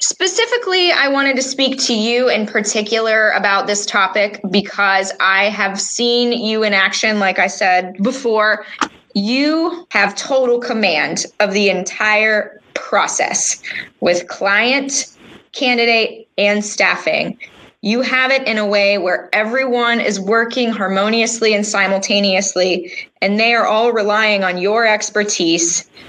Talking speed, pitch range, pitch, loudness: 130 wpm, 200-240 Hz, 215 Hz, -15 LUFS